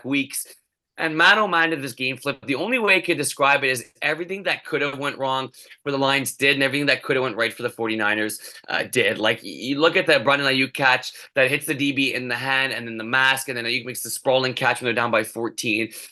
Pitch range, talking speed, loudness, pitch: 120-140 Hz, 270 wpm, -21 LUFS, 135 Hz